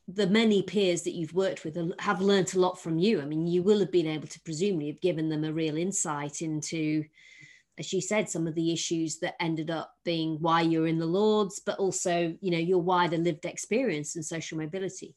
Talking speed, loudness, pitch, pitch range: 220 wpm, -28 LUFS, 170 Hz, 160-190 Hz